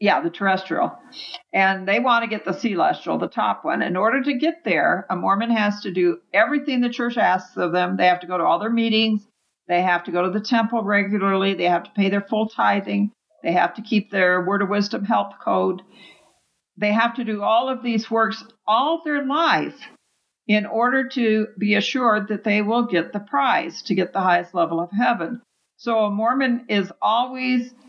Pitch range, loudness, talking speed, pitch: 190-235 Hz, -21 LUFS, 205 wpm, 210 Hz